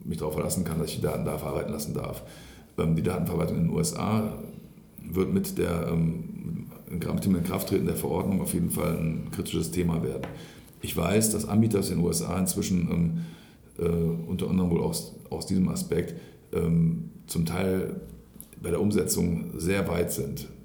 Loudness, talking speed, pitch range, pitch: -28 LUFS, 160 wpm, 85-110 Hz, 90 Hz